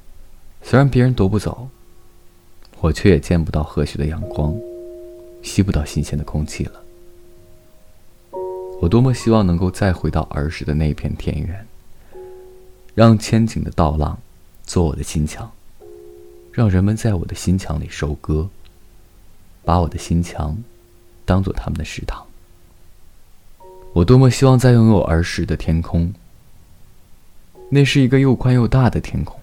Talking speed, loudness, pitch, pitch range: 210 characters per minute, -18 LUFS, 90 Hz, 80-100 Hz